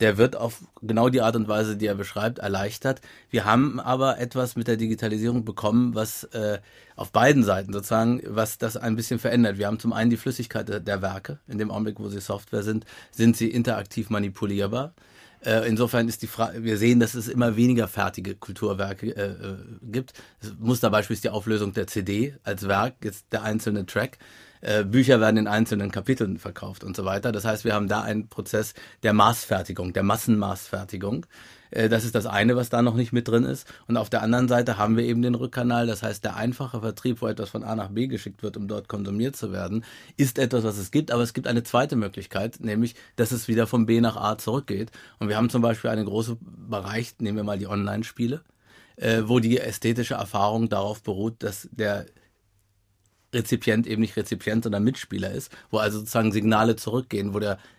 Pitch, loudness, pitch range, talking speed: 110 Hz, -25 LUFS, 105-120 Hz, 195 wpm